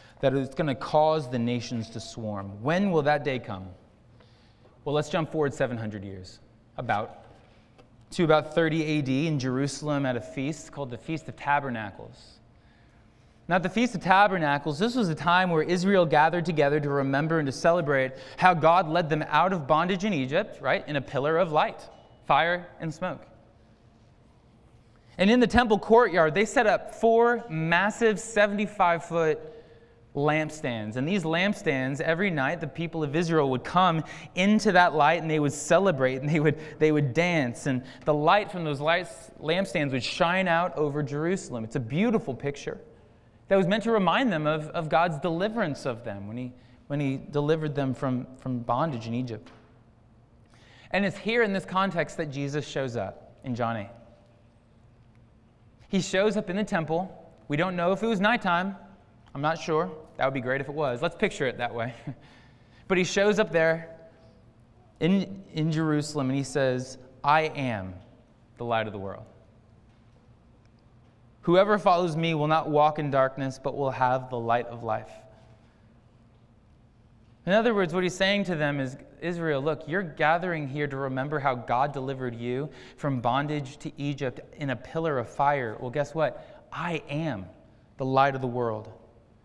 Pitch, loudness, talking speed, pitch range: 145 Hz, -26 LUFS, 175 wpm, 120-170 Hz